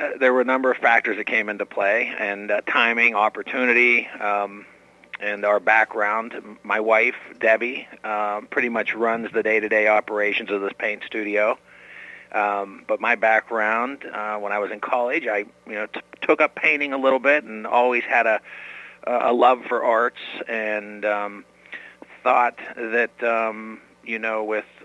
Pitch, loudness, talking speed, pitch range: 110 Hz, -21 LUFS, 165 wpm, 105-120 Hz